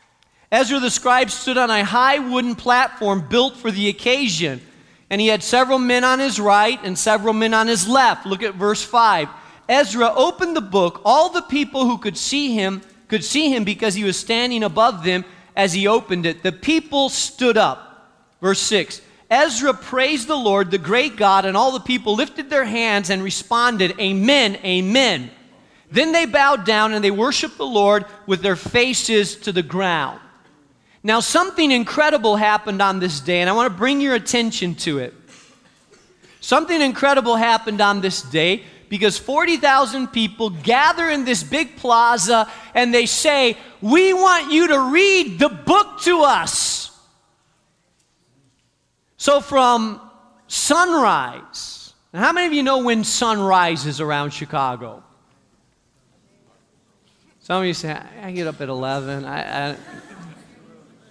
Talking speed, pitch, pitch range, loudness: 160 wpm, 225 Hz, 195-265 Hz, -17 LUFS